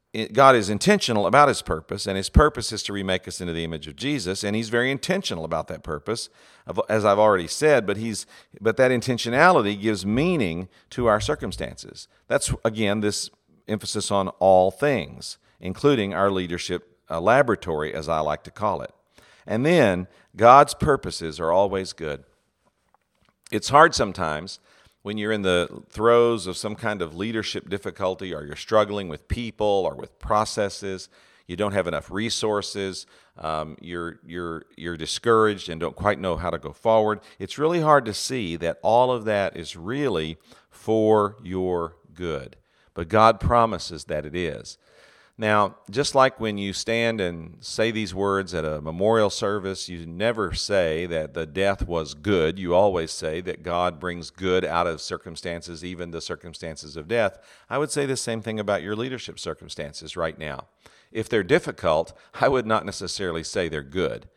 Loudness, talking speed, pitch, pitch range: -23 LUFS, 170 wpm, 100 Hz, 85-110 Hz